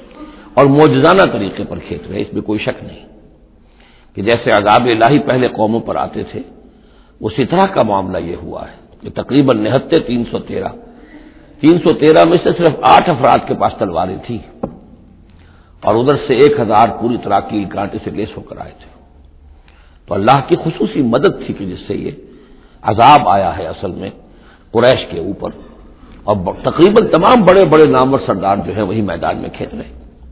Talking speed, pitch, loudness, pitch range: 185 wpm, 110 Hz, -13 LUFS, 95-155 Hz